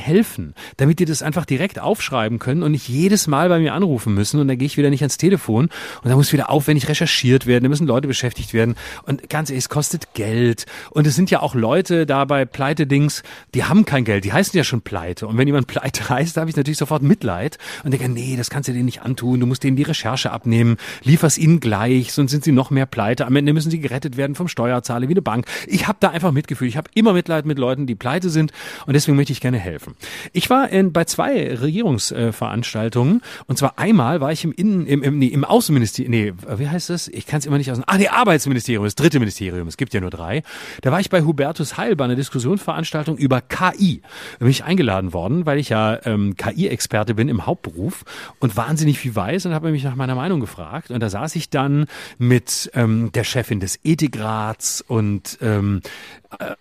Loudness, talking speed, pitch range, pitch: -19 LUFS, 225 wpm, 120-160 Hz, 140 Hz